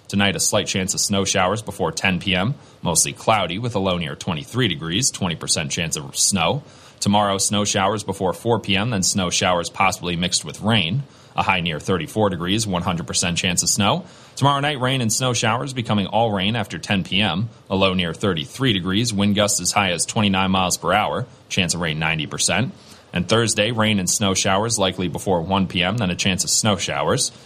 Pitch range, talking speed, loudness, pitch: 95-110 Hz, 195 wpm, -20 LUFS, 100 Hz